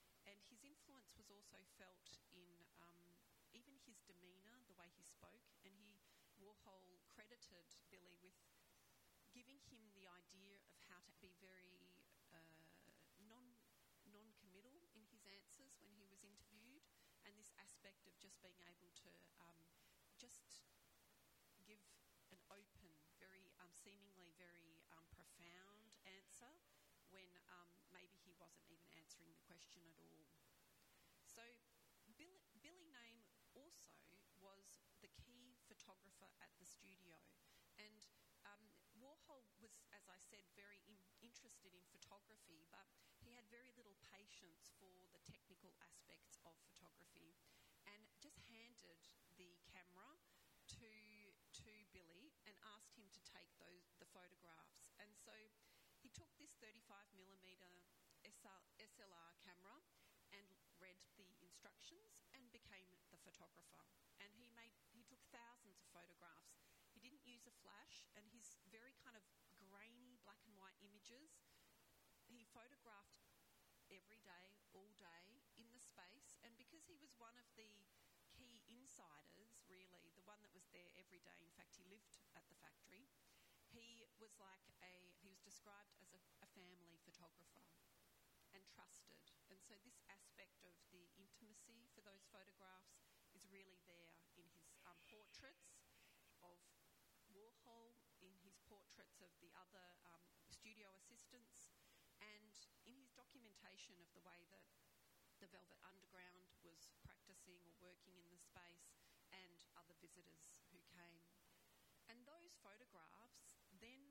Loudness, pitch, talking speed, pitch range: -67 LUFS, 195 Hz, 140 wpm, 180-225 Hz